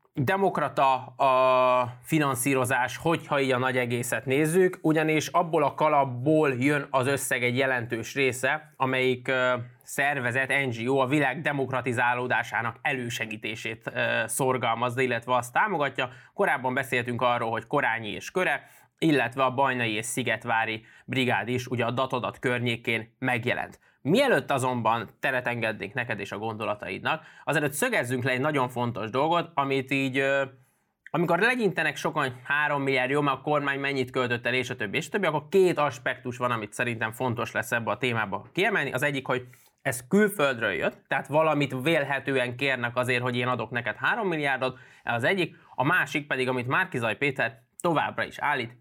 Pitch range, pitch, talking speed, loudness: 125-140 Hz, 130 Hz, 155 wpm, -26 LUFS